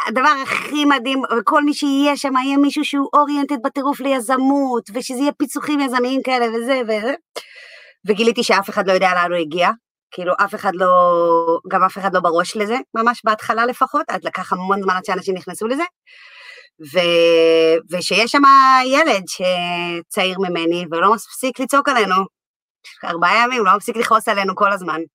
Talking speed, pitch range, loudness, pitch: 160 wpm, 185-275 Hz, -17 LUFS, 225 Hz